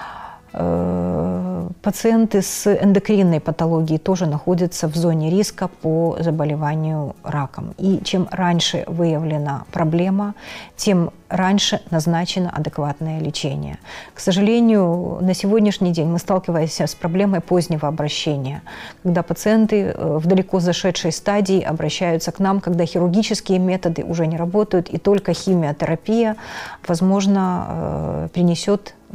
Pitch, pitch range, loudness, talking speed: 175 Hz, 160-195 Hz, -19 LUFS, 110 wpm